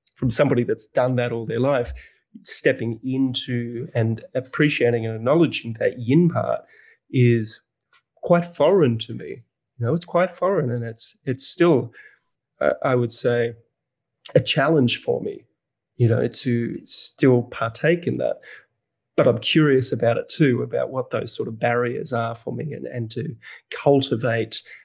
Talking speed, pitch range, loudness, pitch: 155 wpm, 115-140 Hz, -22 LUFS, 120 Hz